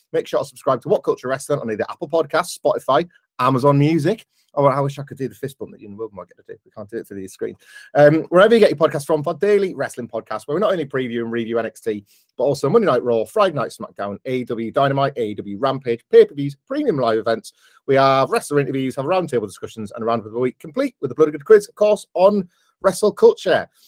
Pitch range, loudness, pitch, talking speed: 115-180 Hz, -19 LUFS, 140 Hz, 240 wpm